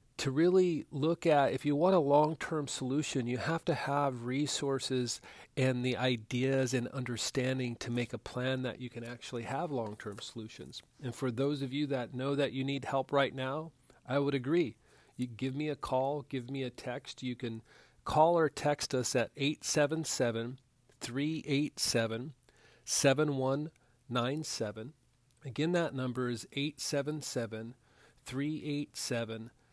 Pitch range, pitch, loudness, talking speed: 125-145 Hz, 130 Hz, -33 LUFS, 150 wpm